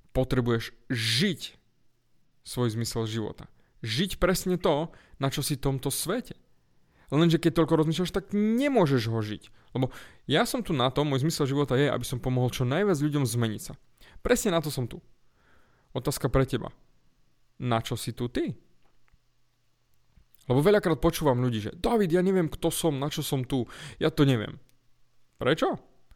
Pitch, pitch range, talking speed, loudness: 135 Hz, 125-165 Hz, 165 wpm, -27 LUFS